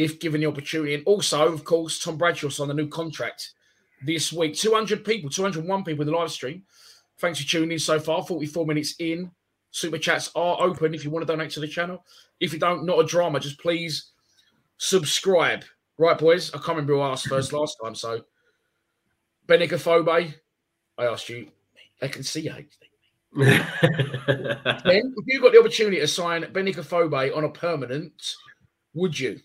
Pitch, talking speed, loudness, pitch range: 165 Hz, 175 wpm, -23 LUFS, 150-175 Hz